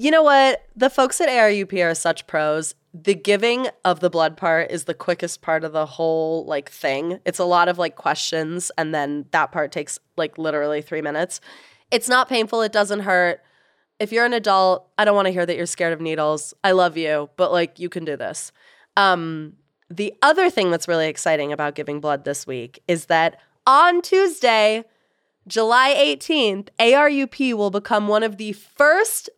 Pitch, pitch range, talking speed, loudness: 180 Hz, 160-225 Hz, 190 wpm, -19 LUFS